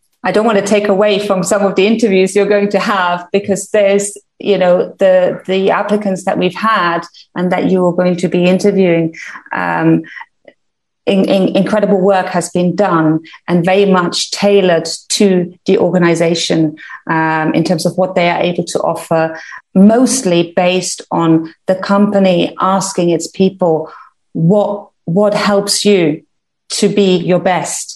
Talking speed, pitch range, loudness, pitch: 160 wpm, 175-200 Hz, -13 LUFS, 185 Hz